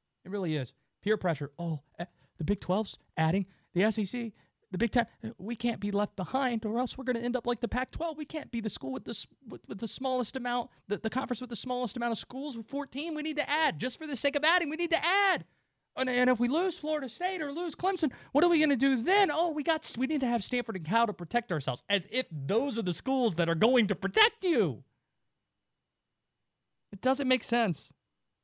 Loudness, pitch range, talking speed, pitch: -31 LUFS, 195-280 Hz, 240 wpm, 240 Hz